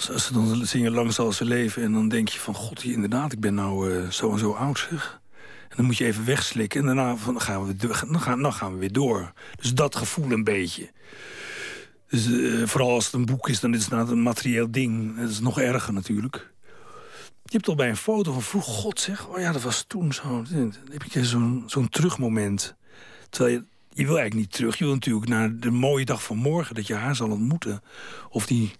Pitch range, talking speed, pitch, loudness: 110-140 Hz, 235 wpm, 120 Hz, -25 LUFS